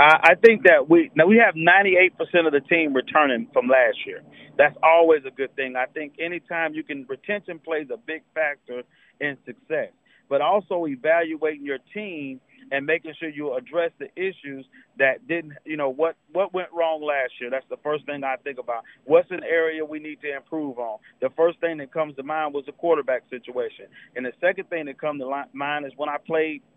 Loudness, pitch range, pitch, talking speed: -22 LUFS, 140-170 Hz, 155 Hz, 205 wpm